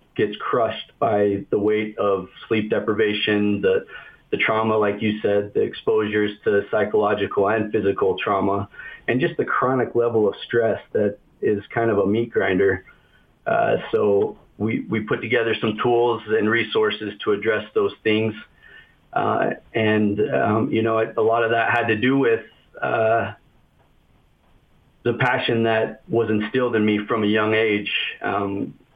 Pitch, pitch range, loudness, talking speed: 110 Hz, 105-120 Hz, -21 LUFS, 155 wpm